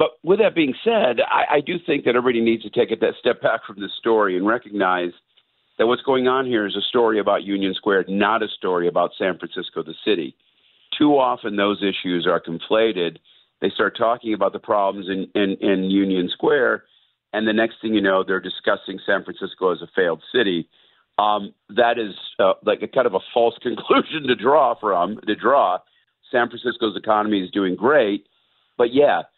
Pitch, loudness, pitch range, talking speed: 105 Hz, -20 LUFS, 95-120 Hz, 195 wpm